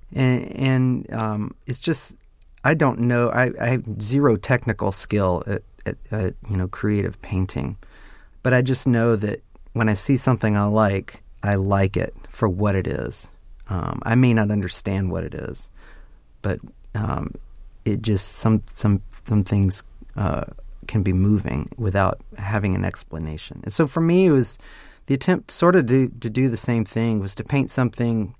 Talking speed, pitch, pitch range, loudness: 175 wpm, 110 Hz, 100-125 Hz, -22 LUFS